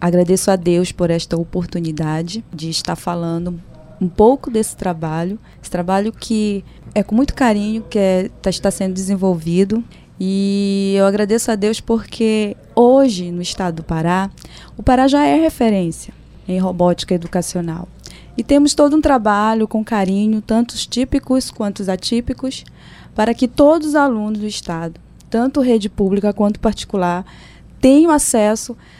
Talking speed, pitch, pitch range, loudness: 145 wpm, 205 Hz, 180-230 Hz, -17 LUFS